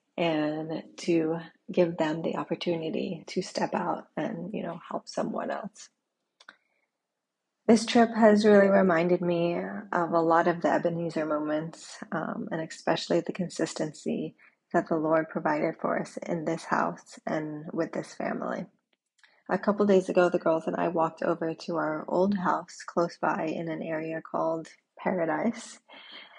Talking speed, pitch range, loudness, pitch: 150 wpm, 160-180 Hz, -28 LUFS, 170 Hz